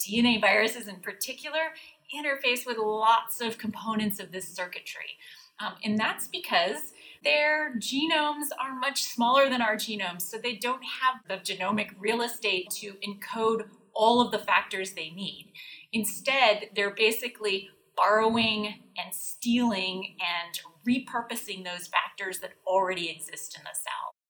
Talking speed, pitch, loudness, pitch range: 140 wpm, 220 Hz, -28 LUFS, 195-245 Hz